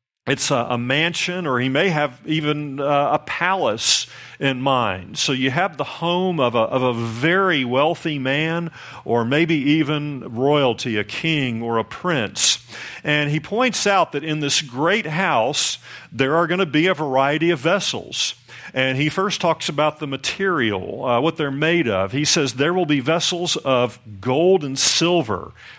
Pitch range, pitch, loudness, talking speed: 130-165 Hz, 145 Hz, -19 LUFS, 175 wpm